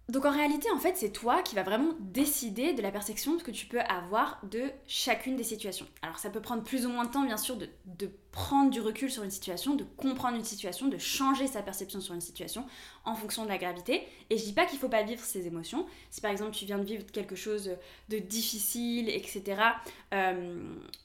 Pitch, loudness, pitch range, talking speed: 225 Hz, -33 LUFS, 205-265 Hz, 230 wpm